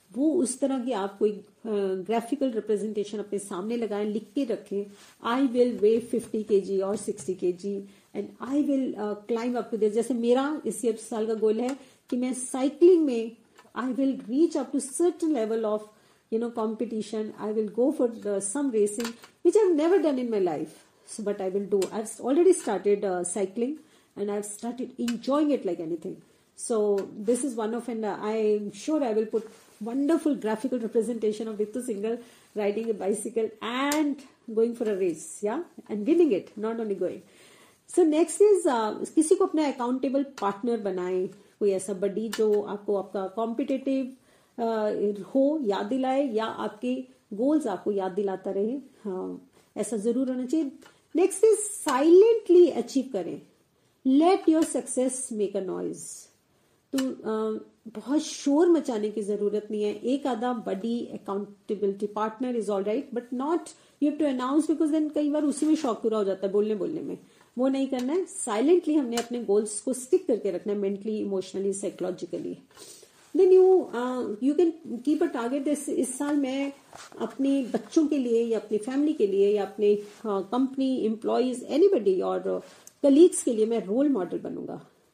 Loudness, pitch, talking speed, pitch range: -27 LUFS, 235 Hz, 170 wpm, 210-280 Hz